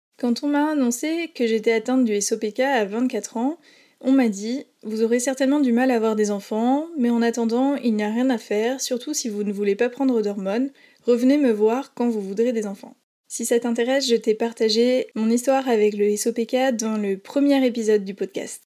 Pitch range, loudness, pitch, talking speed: 220-265 Hz, -22 LUFS, 240 Hz, 210 wpm